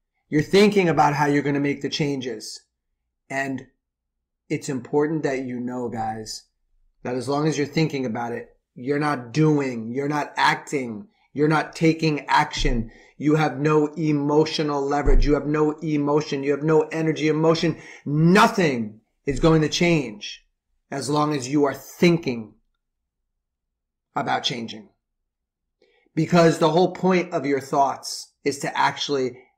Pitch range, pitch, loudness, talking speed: 125-155 Hz, 145 Hz, -22 LUFS, 145 wpm